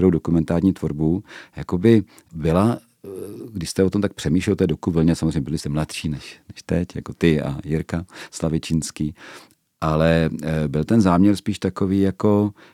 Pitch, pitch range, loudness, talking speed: 85 Hz, 80-95 Hz, -21 LUFS, 150 wpm